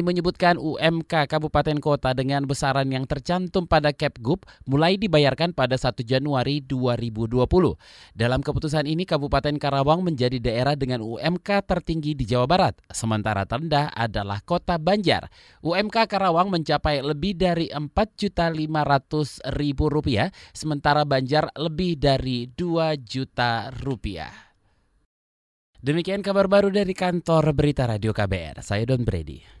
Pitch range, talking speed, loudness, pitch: 125-165 Hz, 115 wpm, -23 LUFS, 145 Hz